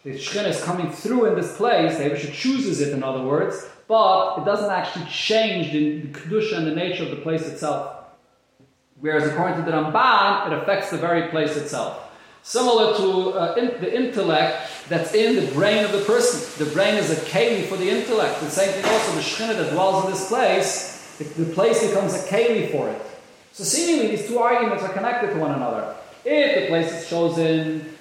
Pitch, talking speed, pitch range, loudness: 180 Hz, 205 wpm, 155-215 Hz, -21 LUFS